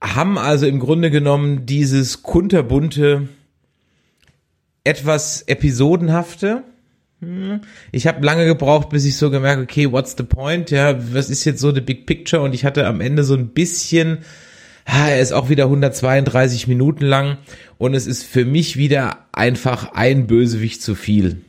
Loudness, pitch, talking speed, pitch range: -16 LUFS, 140 Hz, 155 wpm, 130-155 Hz